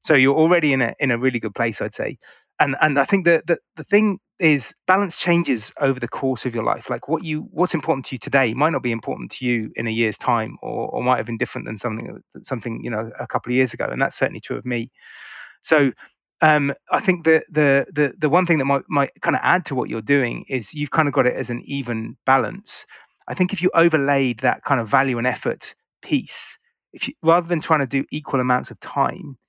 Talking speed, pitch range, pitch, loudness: 250 wpm, 125-160 Hz, 140 Hz, -21 LUFS